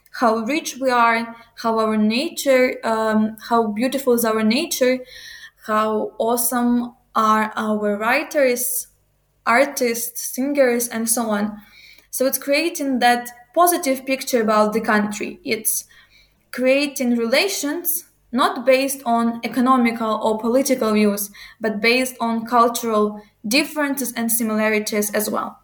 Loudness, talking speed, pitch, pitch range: -19 LUFS, 120 wpm, 240 Hz, 220-265 Hz